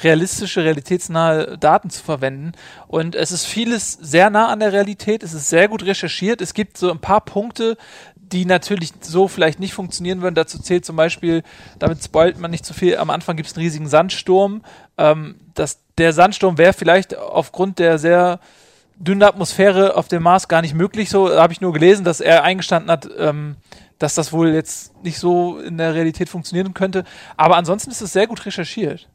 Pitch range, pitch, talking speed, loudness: 165-195 Hz, 175 Hz, 195 wpm, -17 LUFS